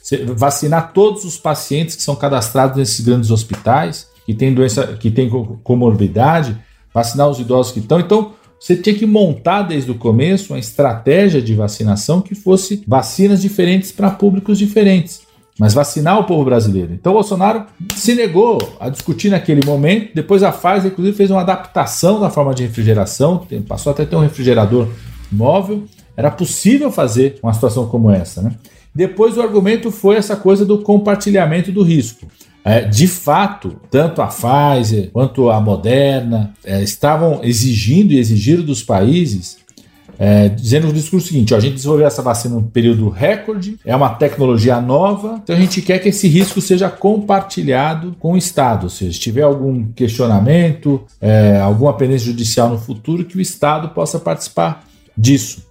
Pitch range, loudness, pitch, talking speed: 115-185 Hz, -14 LUFS, 145 Hz, 165 wpm